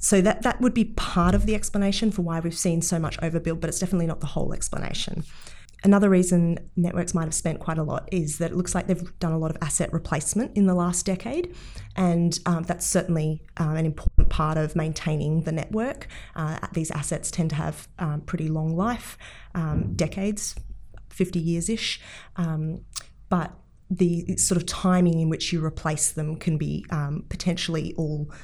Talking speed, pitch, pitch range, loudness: 190 wpm, 170 Hz, 160-185 Hz, -25 LUFS